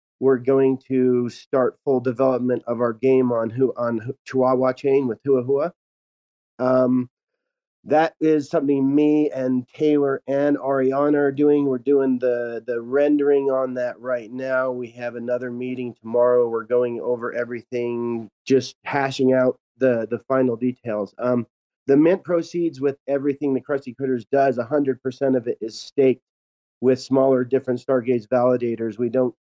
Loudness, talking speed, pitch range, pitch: -21 LUFS, 155 wpm, 120-135 Hz, 130 Hz